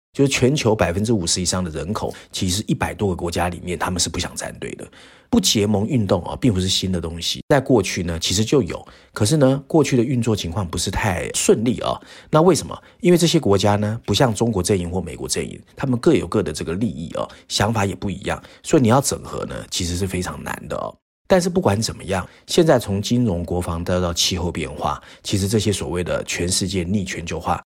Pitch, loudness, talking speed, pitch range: 100 Hz, -20 LUFS, 340 characters per minute, 90-115 Hz